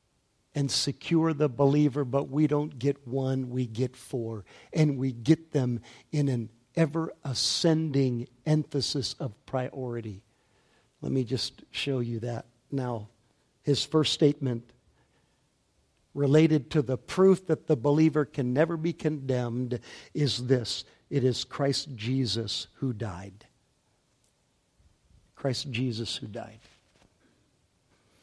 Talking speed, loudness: 115 wpm, -28 LUFS